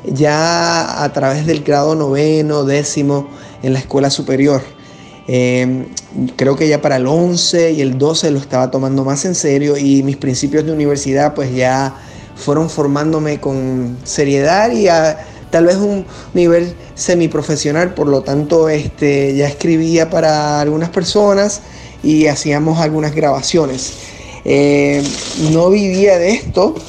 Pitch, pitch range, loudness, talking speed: 145 Hz, 140-160 Hz, -14 LUFS, 140 wpm